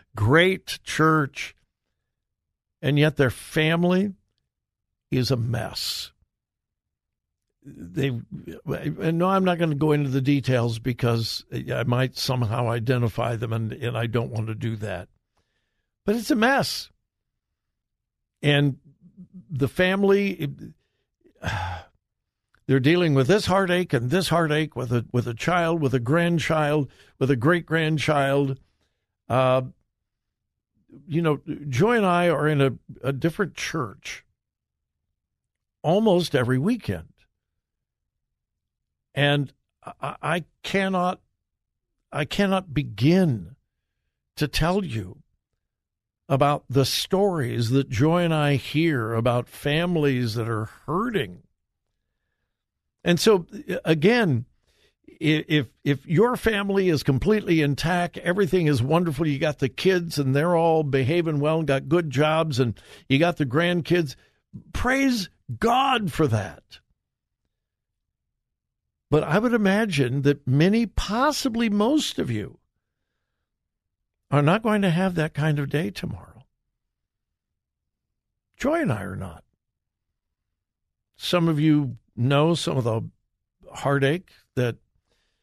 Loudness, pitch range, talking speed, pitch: -23 LUFS, 125-175 Hz, 120 wpm, 150 Hz